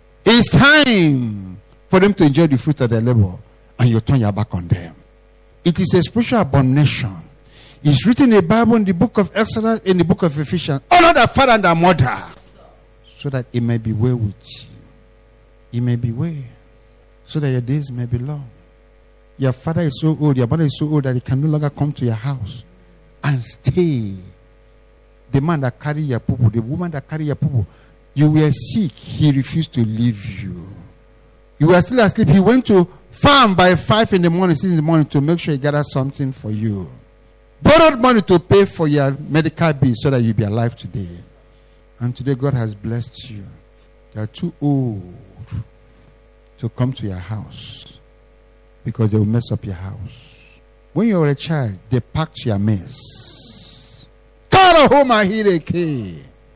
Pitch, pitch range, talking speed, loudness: 130 Hz, 110-155 Hz, 190 wpm, -16 LUFS